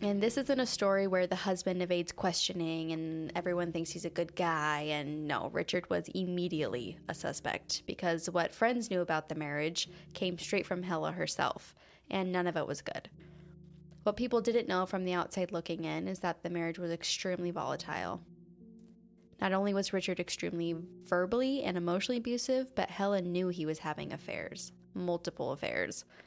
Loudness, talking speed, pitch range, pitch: -34 LUFS, 175 wpm, 165-190 Hz, 175 Hz